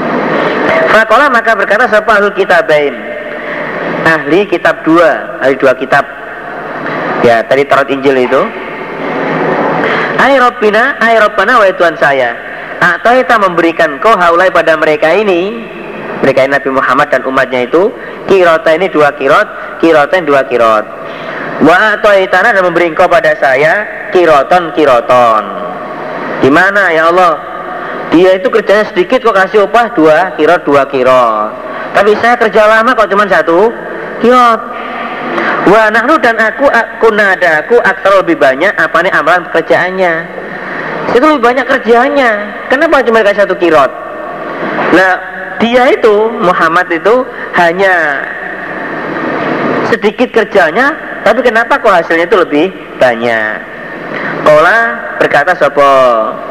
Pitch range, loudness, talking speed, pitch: 160-230 Hz, -8 LUFS, 120 wpm, 205 Hz